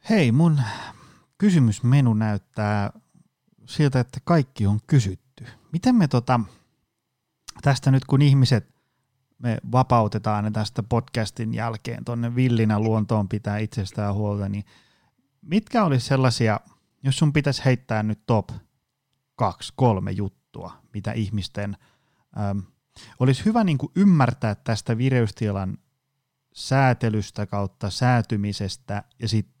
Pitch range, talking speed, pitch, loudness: 105-135 Hz, 110 wpm, 120 Hz, -23 LUFS